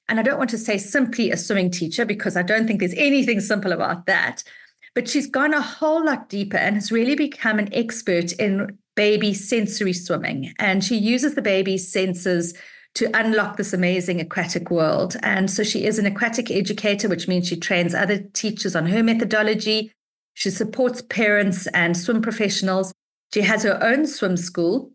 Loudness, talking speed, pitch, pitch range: -21 LUFS, 185 wpm, 210 Hz, 190-230 Hz